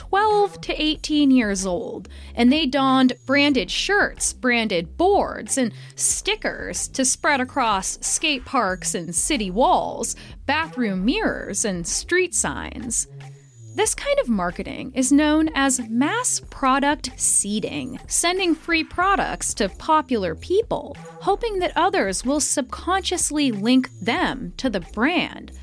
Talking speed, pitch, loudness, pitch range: 125 wpm, 270 Hz, -21 LUFS, 225-315 Hz